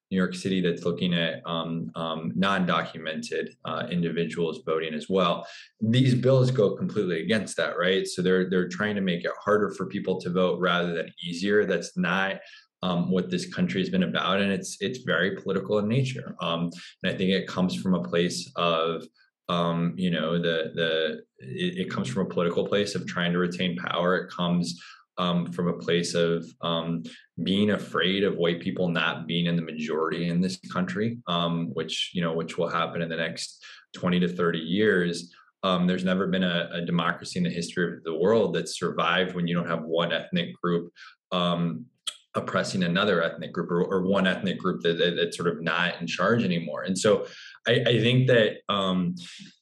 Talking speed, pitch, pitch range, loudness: 195 wpm, 90 Hz, 85-95 Hz, -26 LUFS